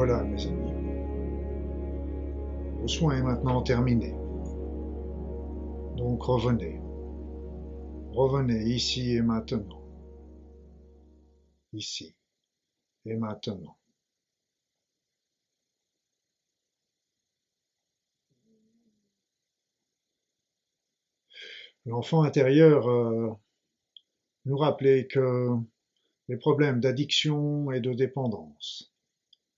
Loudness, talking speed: -28 LUFS, 60 wpm